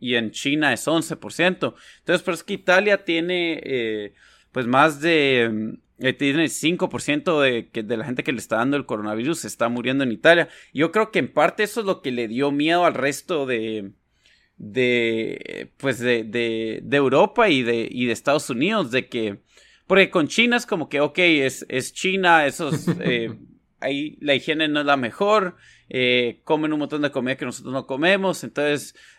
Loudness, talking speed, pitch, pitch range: -21 LUFS, 190 wpm, 145 Hz, 125-170 Hz